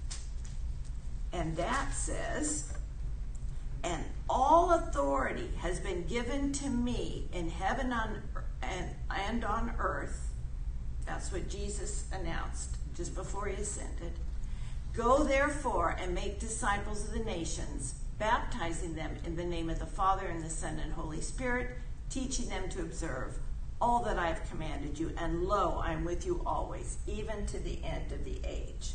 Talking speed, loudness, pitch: 150 wpm, -35 LUFS, 140 Hz